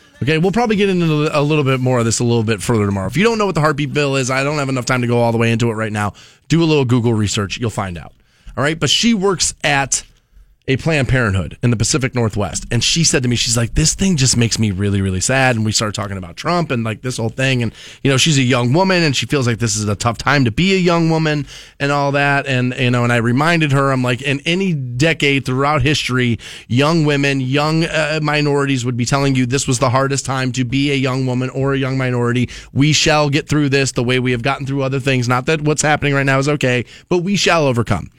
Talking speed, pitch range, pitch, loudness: 270 wpm, 120-150 Hz, 135 Hz, -16 LUFS